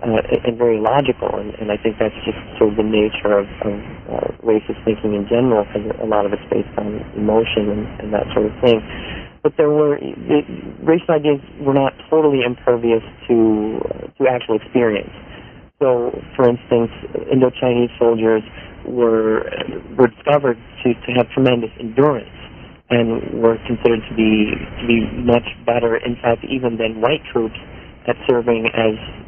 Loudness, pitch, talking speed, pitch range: -18 LUFS, 115 Hz, 170 wpm, 110-125 Hz